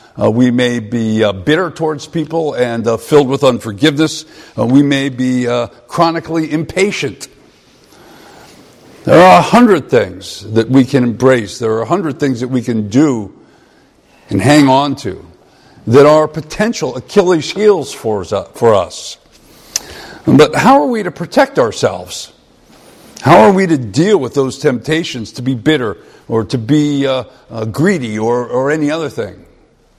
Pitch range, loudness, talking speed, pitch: 120-155 Hz, -12 LUFS, 160 wpm, 135 Hz